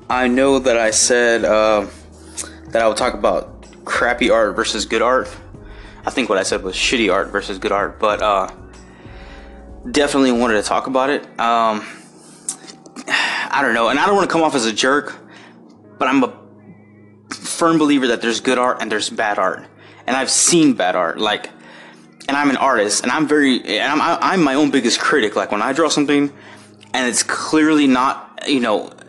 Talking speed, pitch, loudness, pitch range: 190 wpm, 115 Hz, -16 LUFS, 105-140 Hz